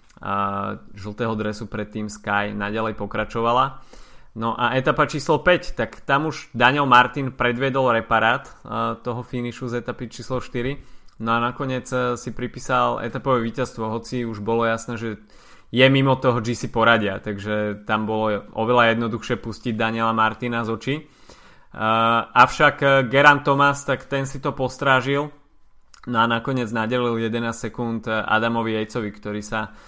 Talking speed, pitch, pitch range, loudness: 145 wpm, 120 Hz, 110-130 Hz, -21 LUFS